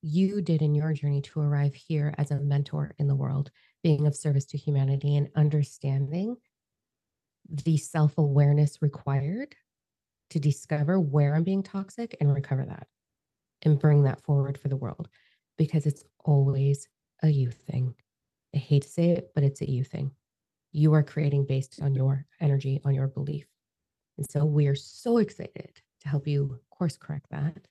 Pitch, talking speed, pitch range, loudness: 145 Hz, 170 wpm, 140-155 Hz, -27 LUFS